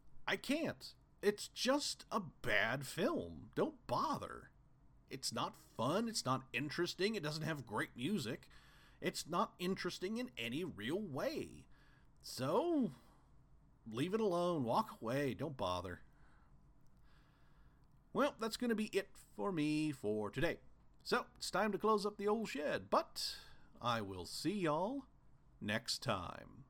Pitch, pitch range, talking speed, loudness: 175 Hz, 130-215 Hz, 135 wpm, -40 LUFS